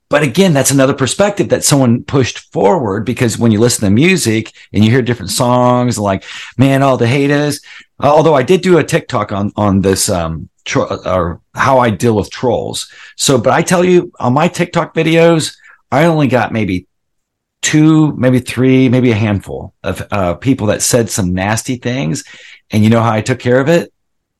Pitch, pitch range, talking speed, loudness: 125 Hz, 105-145 Hz, 190 wpm, -12 LUFS